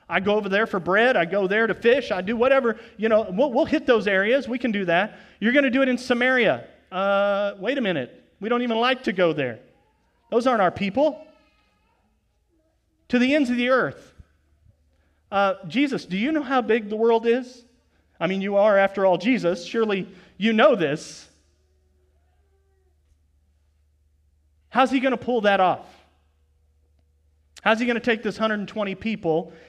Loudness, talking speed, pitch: -22 LUFS, 180 wpm, 200 Hz